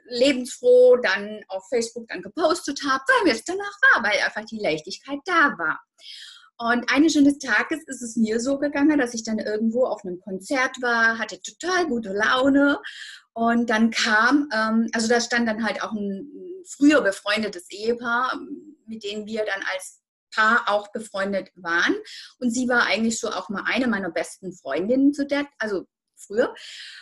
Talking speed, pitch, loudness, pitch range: 170 wpm, 240 Hz, -22 LUFS, 215-285 Hz